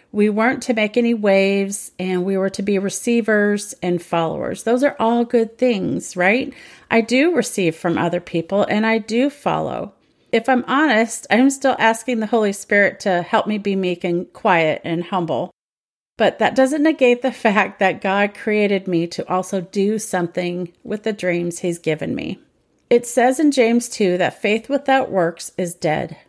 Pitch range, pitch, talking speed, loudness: 180-240 Hz, 210 Hz, 185 wpm, -19 LUFS